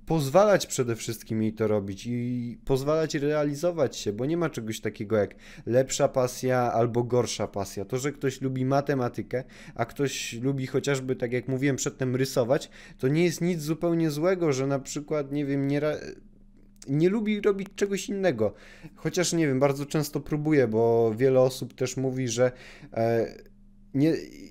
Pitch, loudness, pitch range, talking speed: 135 Hz, -27 LUFS, 120-155 Hz, 165 wpm